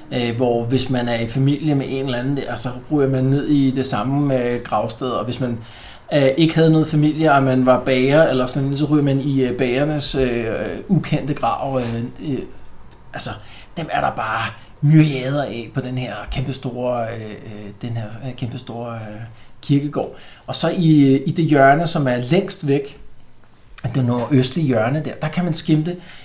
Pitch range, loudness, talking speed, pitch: 120-145 Hz, -19 LUFS, 160 wpm, 130 Hz